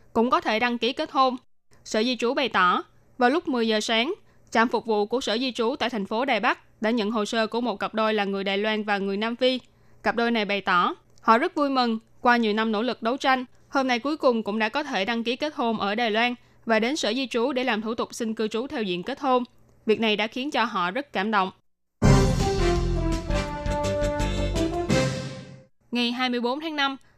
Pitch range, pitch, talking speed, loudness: 205-250 Hz, 225 Hz, 230 wpm, -25 LUFS